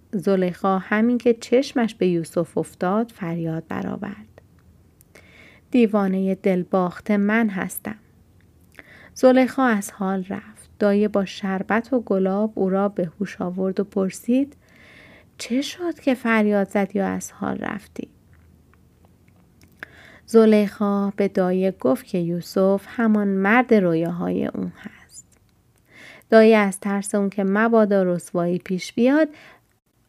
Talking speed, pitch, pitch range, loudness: 120 wpm, 200 Hz, 180-220 Hz, -21 LUFS